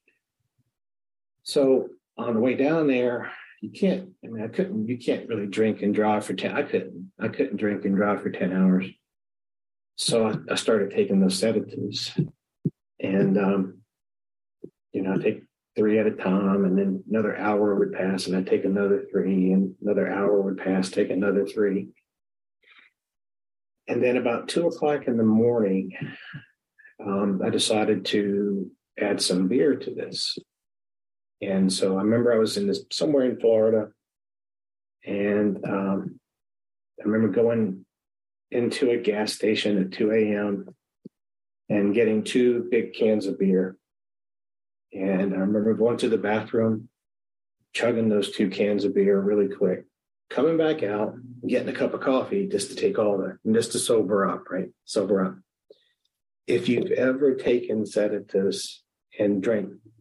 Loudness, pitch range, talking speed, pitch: -24 LUFS, 95-120 Hz, 155 wpm, 105 Hz